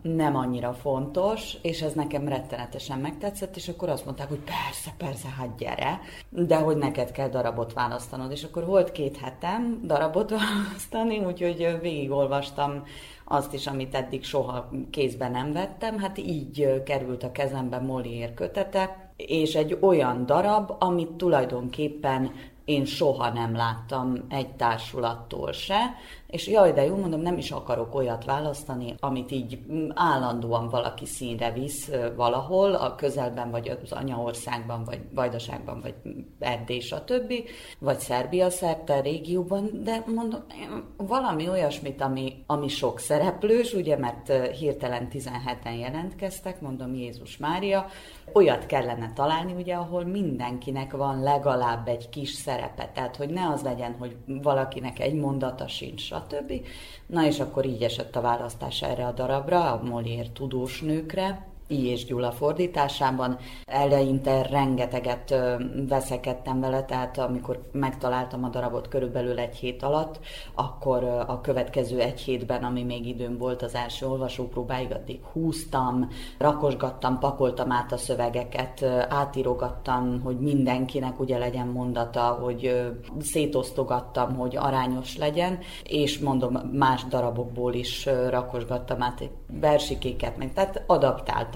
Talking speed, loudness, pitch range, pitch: 135 wpm, -28 LUFS, 125-150 Hz, 135 Hz